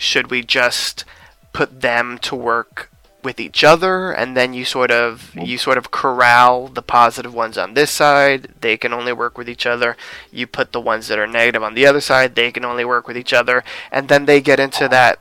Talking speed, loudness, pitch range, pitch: 220 wpm, -15 LUFS, 120-135 Hz, 125 Hz